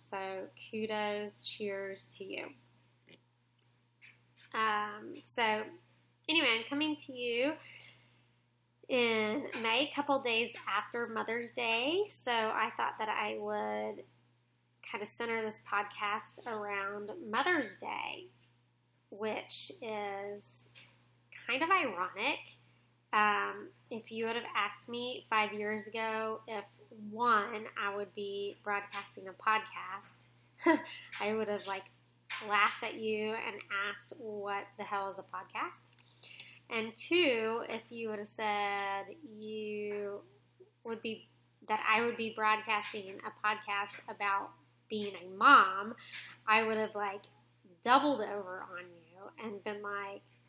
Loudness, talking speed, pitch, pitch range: -34 LUFS, 125 wpm, 210 Hz, 185-225 Hz